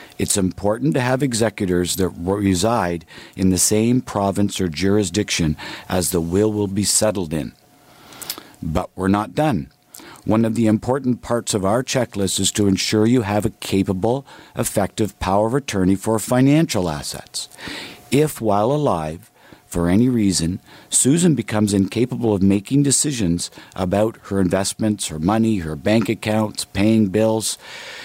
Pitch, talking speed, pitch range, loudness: 105 Hz, 145 wpm, 95-115 Hz, -19 LUFS